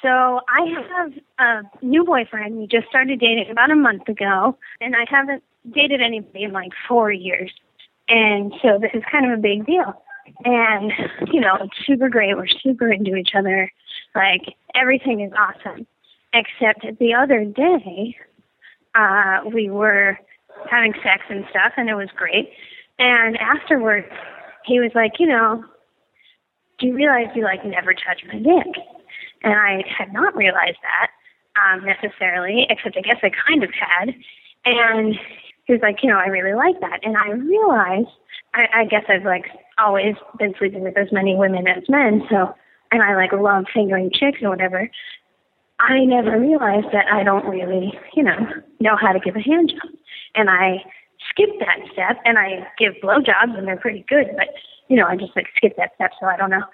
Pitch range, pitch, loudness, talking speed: 195-260 Hz, 220 Hz, -17 LUFS, 180 wpm